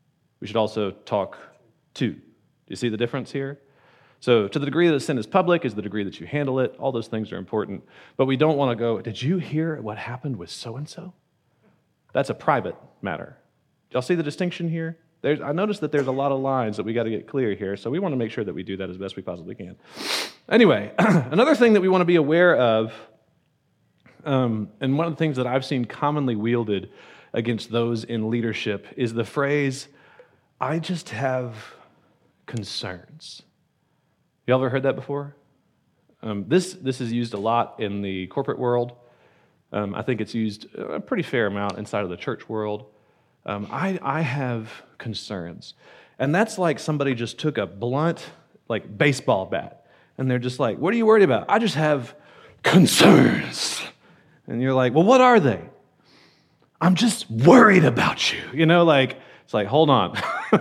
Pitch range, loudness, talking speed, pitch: 110-155 Hz, -22 LUFS, 190 wpm, 130 Hz